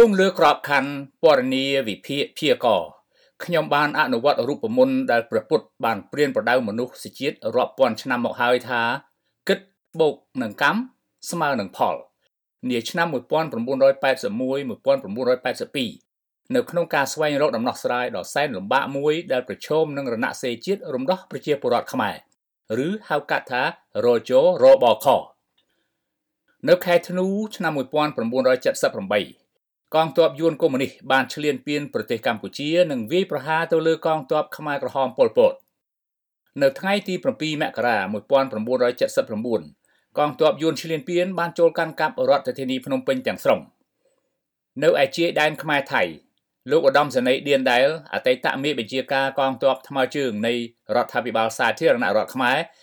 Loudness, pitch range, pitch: -22 LUFS, 135-185 Hz, 155 Hz